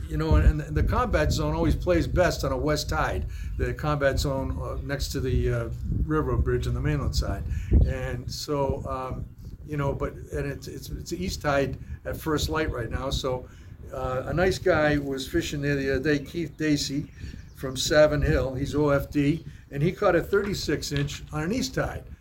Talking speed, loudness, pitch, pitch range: 195 wpm, -27 LUFS, 135 Hz, 100-150 Hz